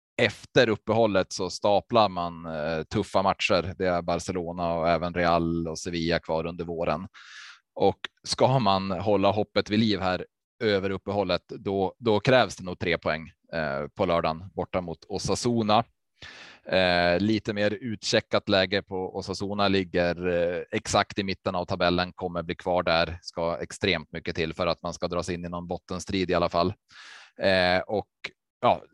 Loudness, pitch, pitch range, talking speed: -26 LUFS, 90 Hz, 85-100 Hz, 155 wpm